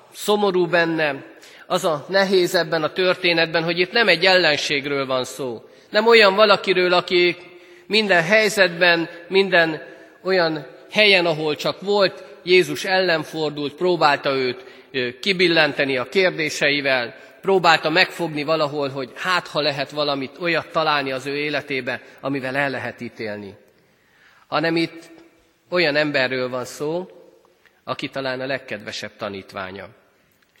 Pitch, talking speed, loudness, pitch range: 165 Hz, 125 wpm, -19 LUFS, 140-180 Hz